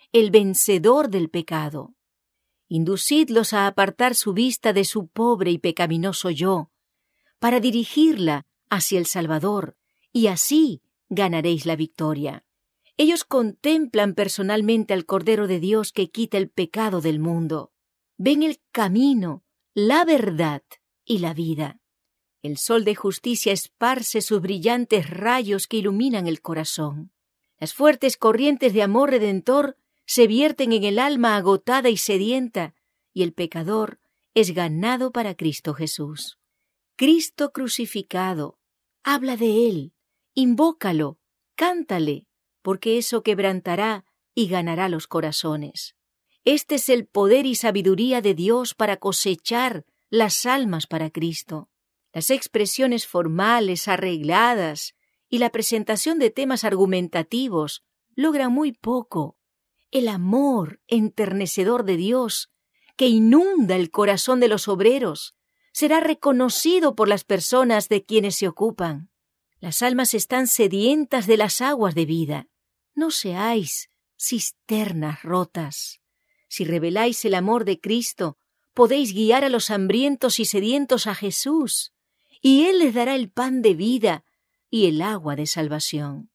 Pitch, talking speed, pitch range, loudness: 215 Hz, 125 wpm, 180-250 Hz, -21 LUFS